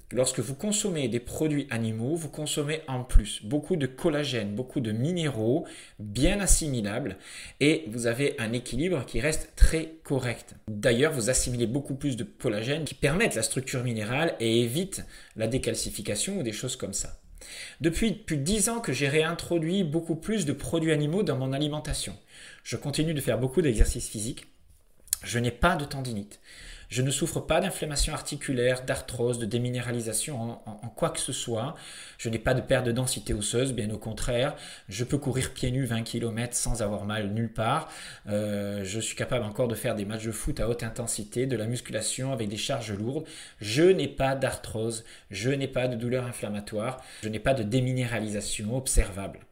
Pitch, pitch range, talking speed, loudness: 125 Hz, 115-150 Hz, 185 wpm, -29 LUFS